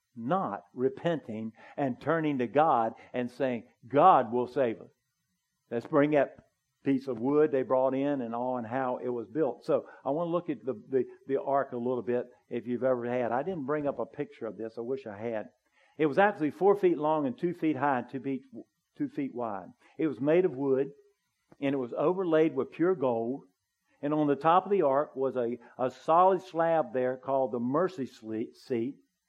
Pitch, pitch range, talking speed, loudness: 135 Hz, 125-155 Hz, 210 wpm, -30 LUFS